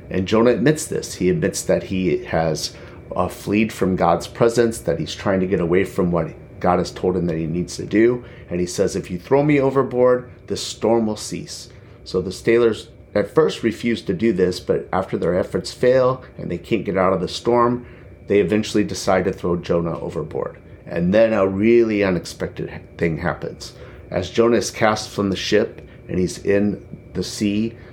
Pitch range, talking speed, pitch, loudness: 90-120 Hz, 195 wpm, 105 Hz, -20 LUFS